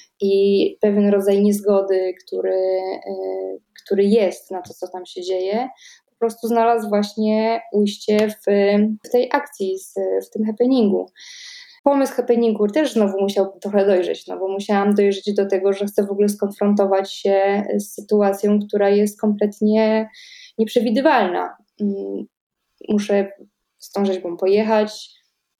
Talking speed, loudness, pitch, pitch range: 125 wpm, -19 LUFS, 205 Hz, 195-220 Hz